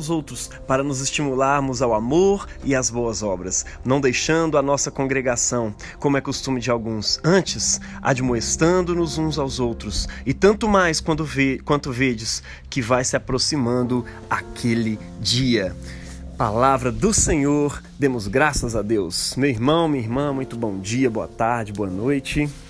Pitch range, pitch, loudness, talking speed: 115-140 Hz, 130 Hz, -21 LUFS, 150 wpm